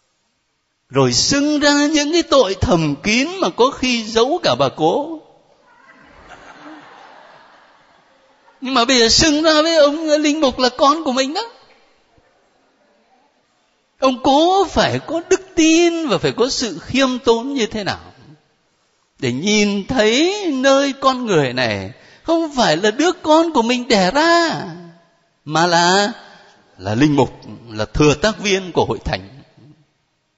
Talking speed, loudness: 145 wpm, -16 LUFS